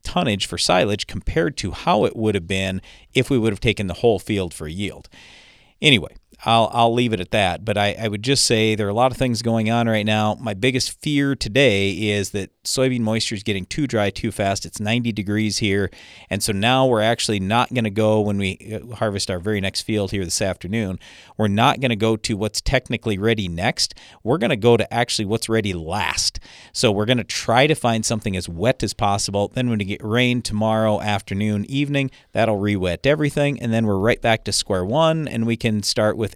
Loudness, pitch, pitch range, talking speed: -20 LUFS, 110 Hz, 100-120 Hz, 225 wpm